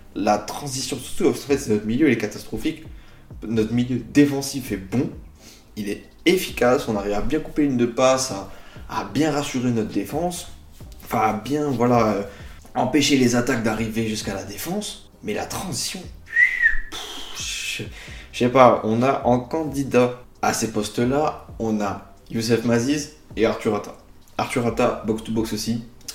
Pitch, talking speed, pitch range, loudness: 120 Hz, 150 wpm, 105-140 Hz, -22 LUFS